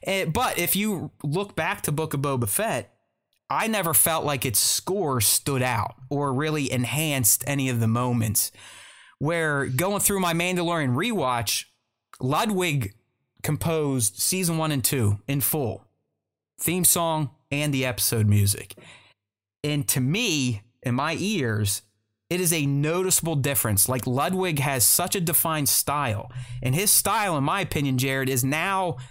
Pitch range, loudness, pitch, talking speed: 120-160 Hz, -23 LUFS, 140 Hz, 150 wpm